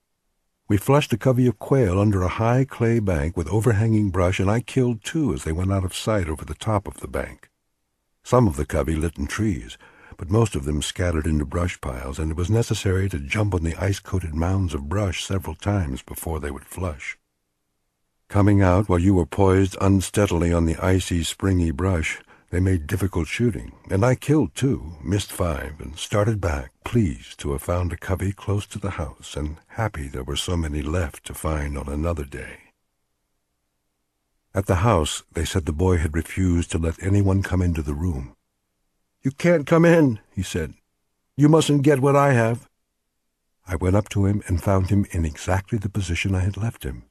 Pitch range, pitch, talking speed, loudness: 75-105 Hz, 90 Hz, 195 wpm, -23 LUFS